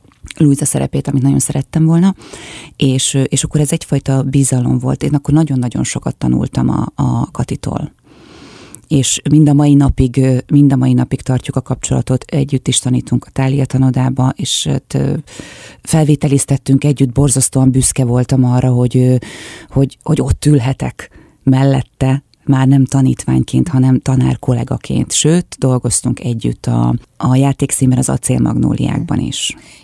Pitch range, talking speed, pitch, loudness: 125-140 Hz, 135 wpm, 130 Hz, -13 LUFS